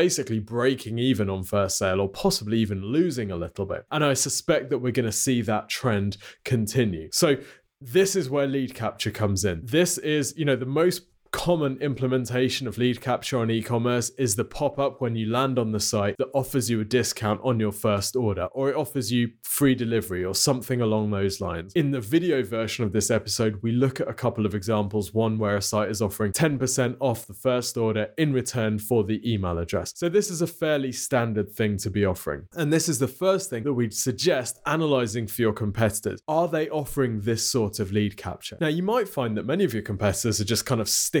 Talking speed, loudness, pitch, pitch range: 220 wpm, -25 LUFS, 120 Hz, 105-135 Hz